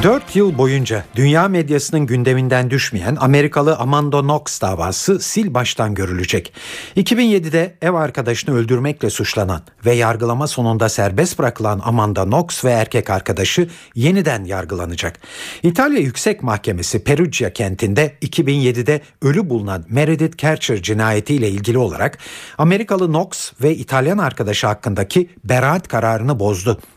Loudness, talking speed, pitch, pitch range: -17 LUFS, 120 wpm, 130 Hz, 110-160 Hz